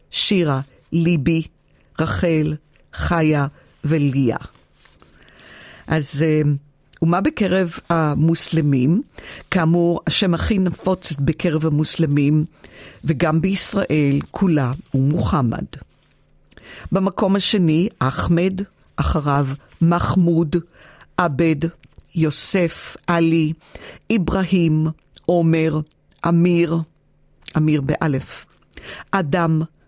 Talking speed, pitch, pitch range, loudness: 70 wpm, 165 Hz, 150-175 Hz, -19 LUFS